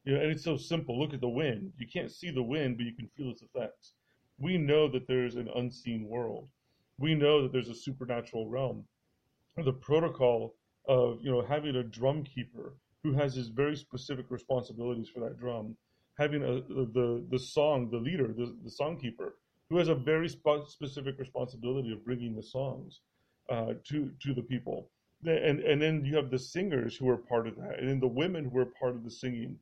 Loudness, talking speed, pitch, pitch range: -33 LUFS, 205 wpm, 130 Hz, 120-145 Hz